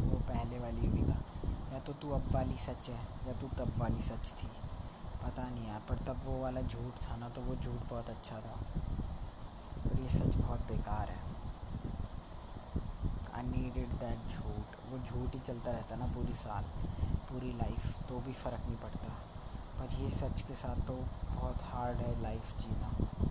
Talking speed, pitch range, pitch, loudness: 180 wpm, 105-125 Hz, 120 Hz, -40 LUFS